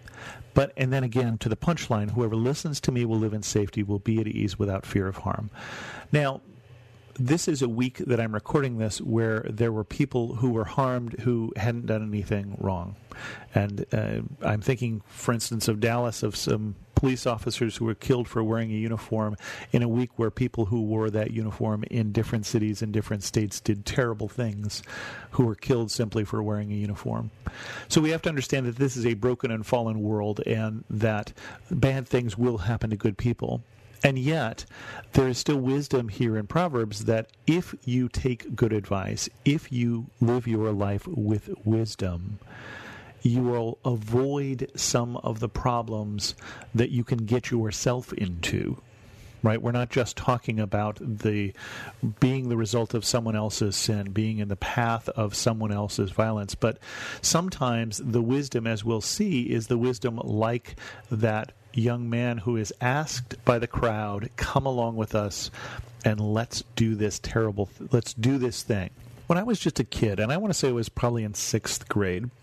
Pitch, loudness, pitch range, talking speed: 115 Hz, -27 LUFS, 110-125 Hz, 180 wpm